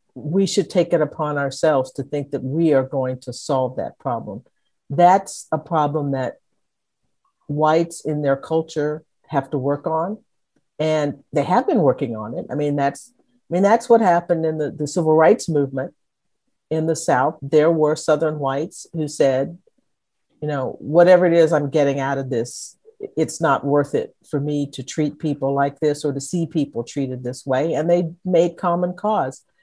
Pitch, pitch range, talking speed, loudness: 150 Hz, 140-170 Hz, 185 wpm, -20 LUFS